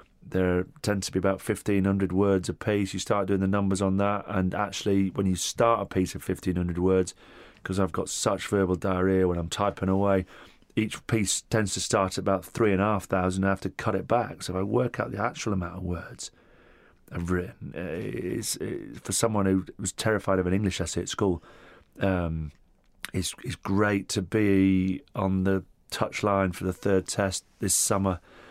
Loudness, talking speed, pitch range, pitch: -27 LUFS, 200 wpm, 95-100 Hz, 95 Hz